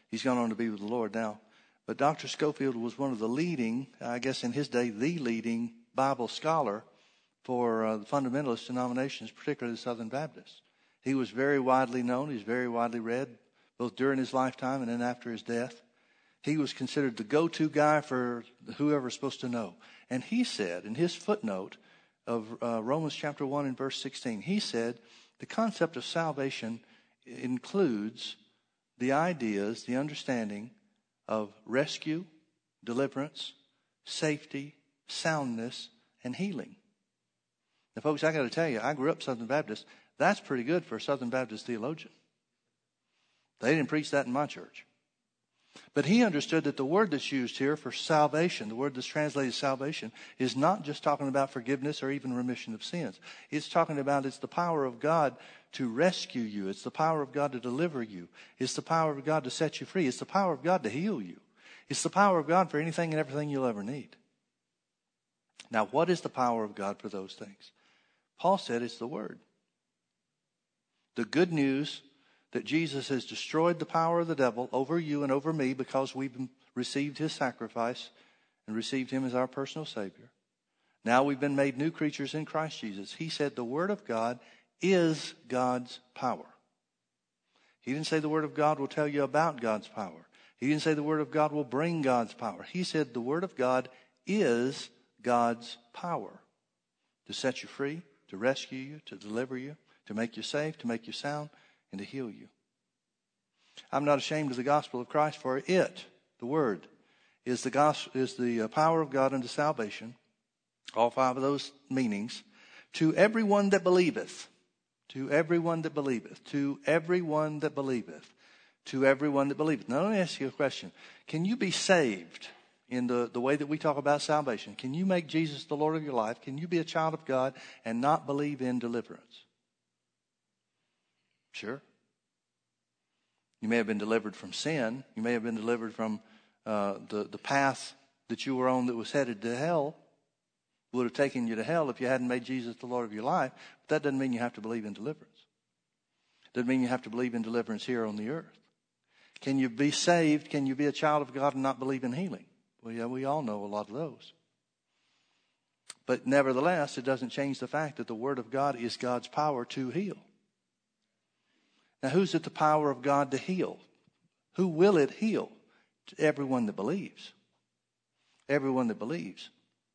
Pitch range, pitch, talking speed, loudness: 120-155 Hz, 135 Hz, 185 wpm, -31 LUFS